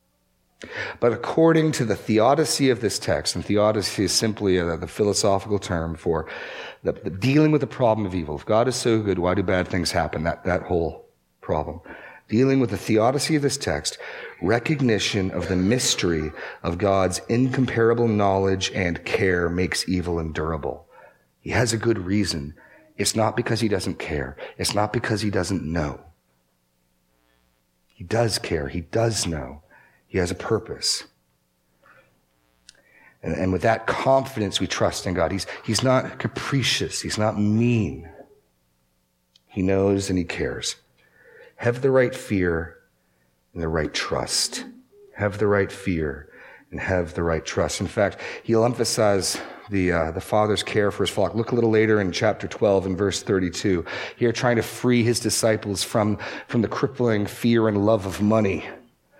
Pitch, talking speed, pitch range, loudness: 100 Hz, 165 wpm, 85-115 Hz, -23 LUFS